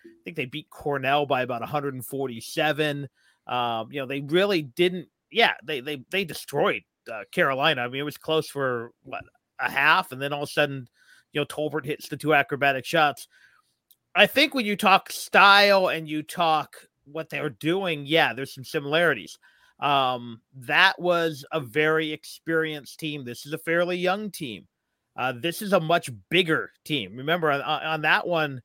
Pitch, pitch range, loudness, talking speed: 150 Hz, 135-170 Hz, -24 LUFS, 180 wpm